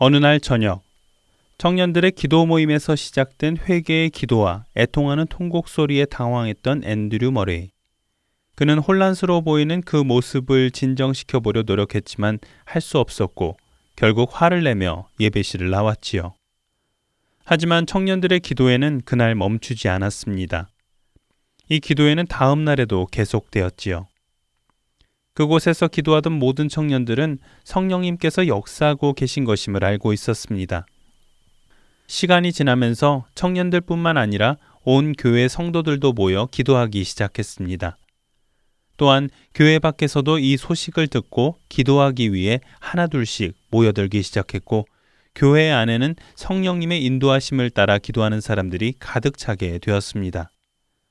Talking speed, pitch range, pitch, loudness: 305 characters per minute, 105-155 Hz, 130 Hz, -19 LUFS